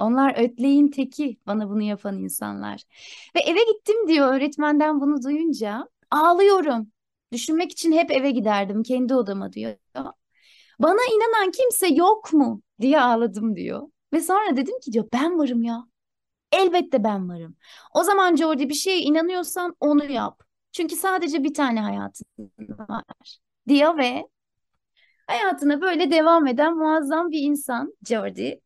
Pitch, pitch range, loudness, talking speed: 290 Hz, 235-330 Hz, -21 LUFS, 140 wpm